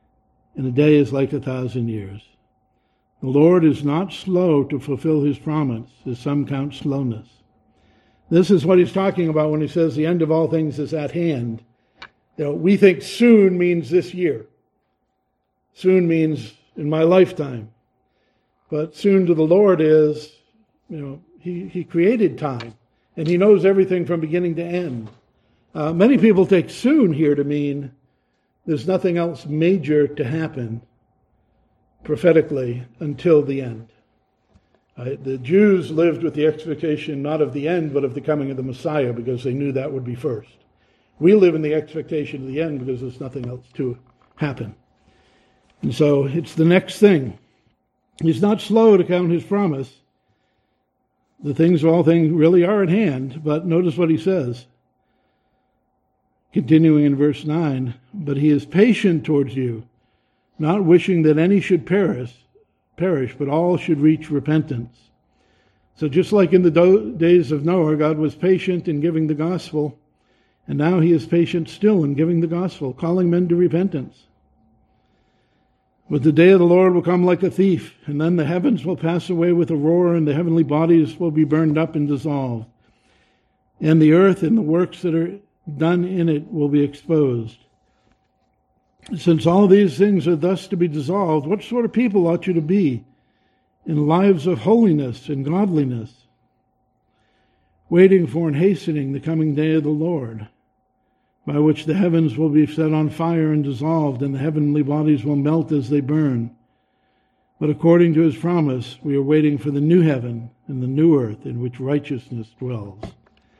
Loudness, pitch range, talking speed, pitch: -18 LUFS, 135-175 Hz, 170 wpm, 155 Hz